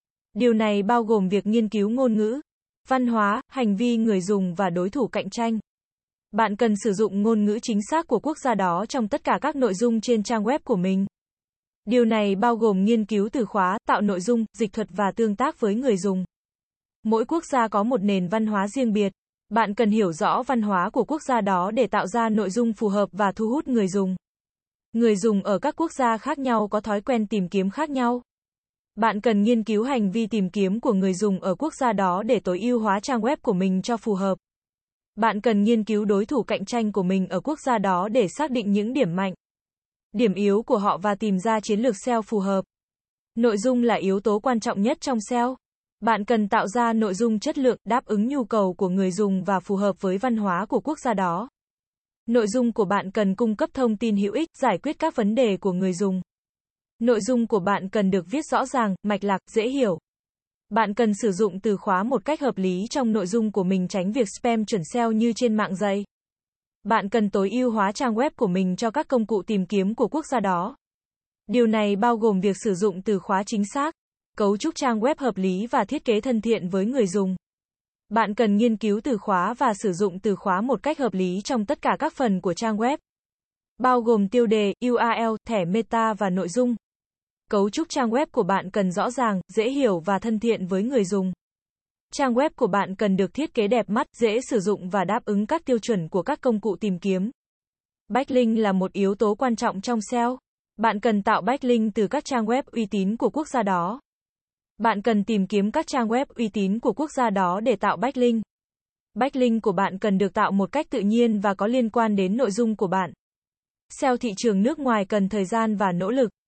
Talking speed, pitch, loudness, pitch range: 230 wpm, 220 Hz, -23 LUFS, 200-245 Hz